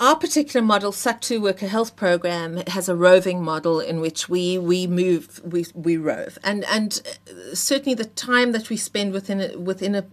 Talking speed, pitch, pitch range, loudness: 185 wpm, 190 Hz, 175-220 Hz, -22 LUFS